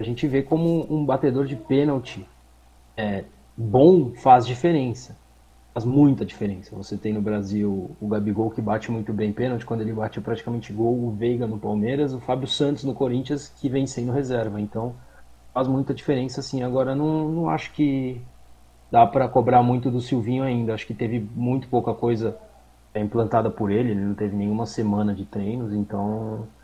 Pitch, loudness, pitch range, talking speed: 115 Hz, -23 LUFS, 105-130 Hz, 175 wpm